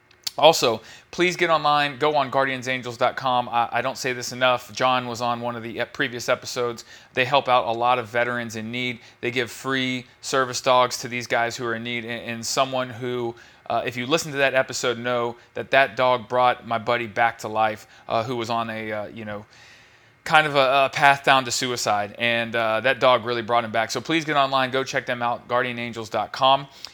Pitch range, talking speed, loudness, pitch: 120-130 Hz, 215 wpm, -22 LUFS, 125 Hz